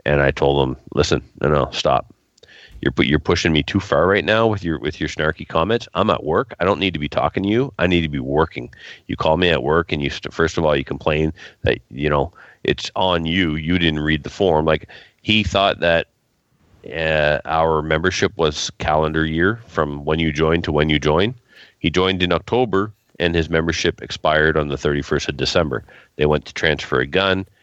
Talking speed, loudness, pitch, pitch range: 215 wpm, -19 LUFS, 80 Hz, 75-95 Hz